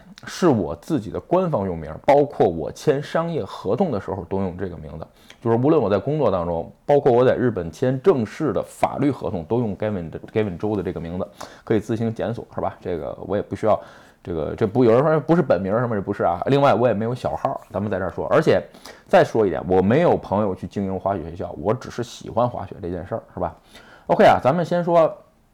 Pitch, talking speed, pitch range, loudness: 110 Hz, 360 characters per minute, 95-130 Hz, -21 LUFS